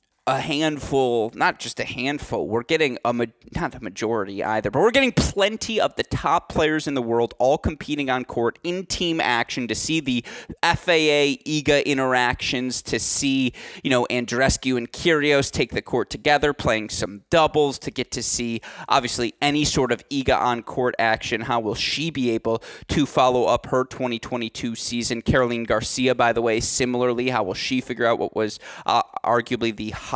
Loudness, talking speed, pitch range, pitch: -22 LUFS, 185 wpm, 120-145 Hz, 125 Hz